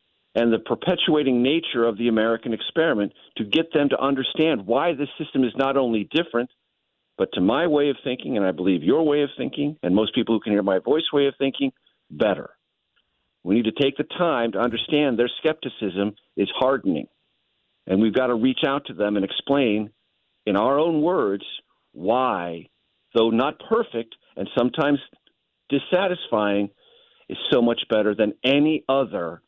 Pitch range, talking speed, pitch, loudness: 110-145 Hz, 175 wpm, 125 Hz, -22 LUFS